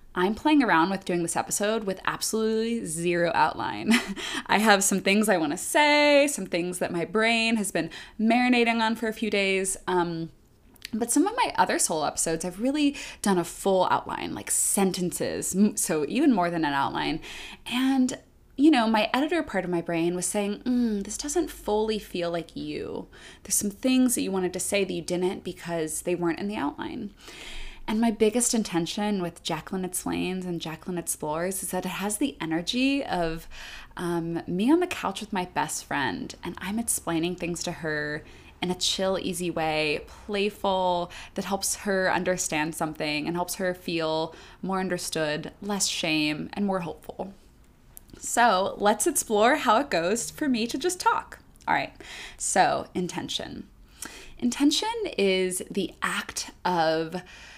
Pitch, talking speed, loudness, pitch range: 190 Hz, 170 wpm, -26 LUFS, 170-230 Hz